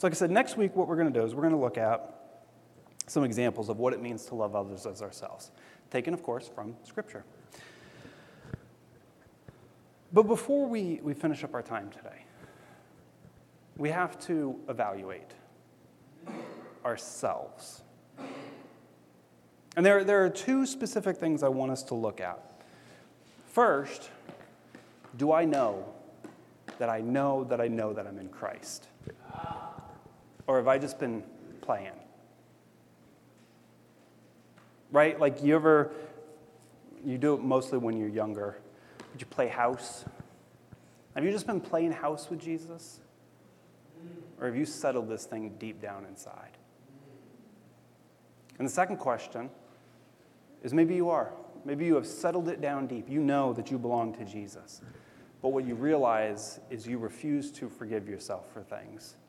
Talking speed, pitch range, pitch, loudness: 150 wpm, 110-165 Hz, 135 Hz, -31 LUFS